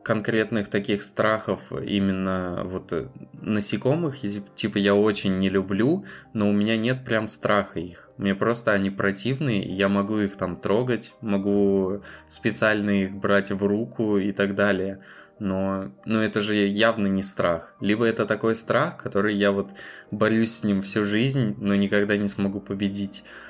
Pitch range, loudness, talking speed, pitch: 100-110 Hz, -24 LUFS, 155 wpm, 100 Hz